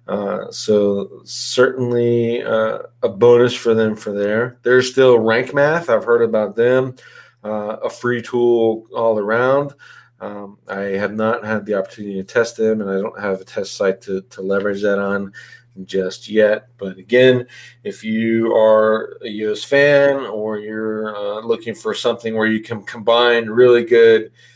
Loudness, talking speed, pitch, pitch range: -17 LUFS, 165 wpm, 110 Hz, 105-120 Hz